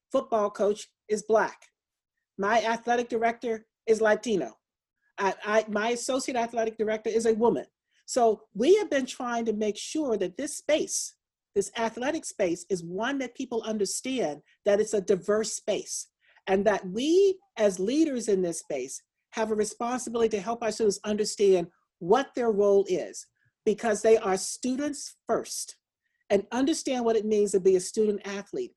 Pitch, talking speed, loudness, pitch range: 225 Hz, 160 wpm, -27 LUFS, 205-250 Hz